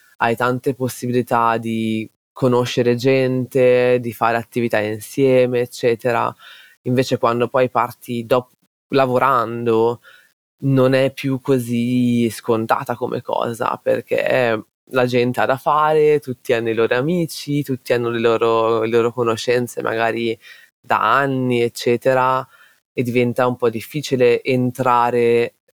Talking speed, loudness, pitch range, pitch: 120 wpm, -18 LUFS, 115-130 Hz, 125 Hz